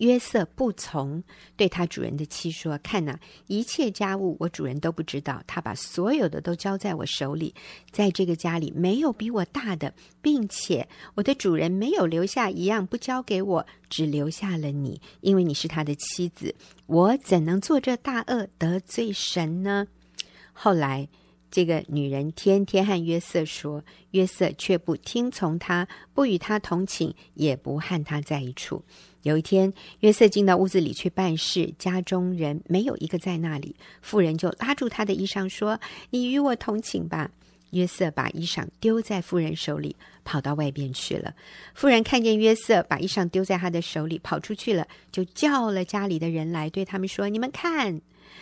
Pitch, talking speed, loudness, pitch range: 185 Hz, 260 characters per minute, -26 LUFS, 160-205 Hz